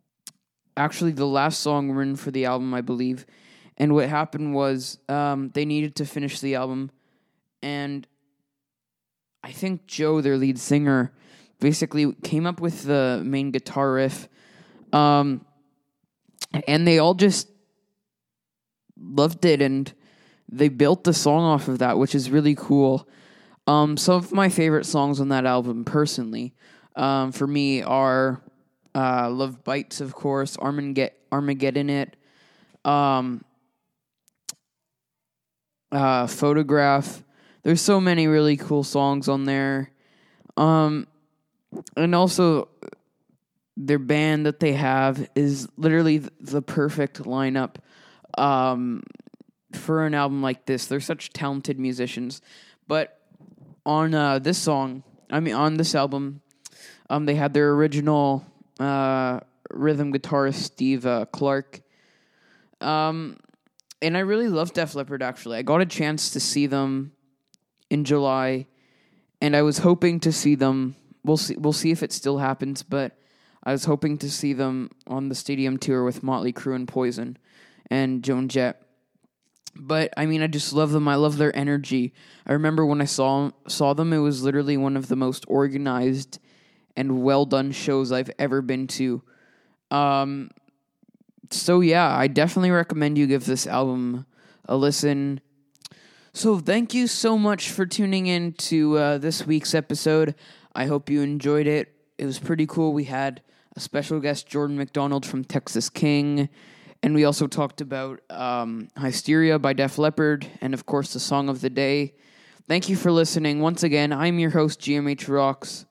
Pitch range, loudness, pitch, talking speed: 135-155 Hz, -23 LUFS, 145 Hz, 150 wpm